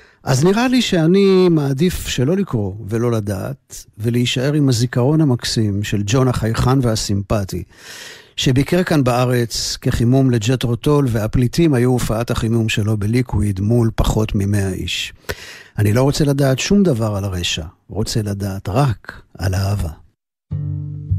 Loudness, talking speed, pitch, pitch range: -17 LUFS, 125 wpm, 120 Hz, 105-135 Hz